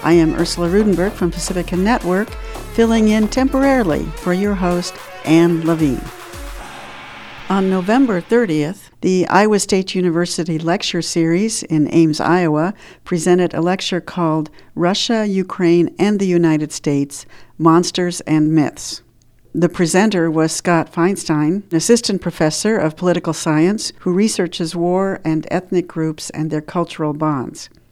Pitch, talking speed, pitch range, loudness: 175 Hz, 130 wpm, 160-190 Hz, -17 LUFS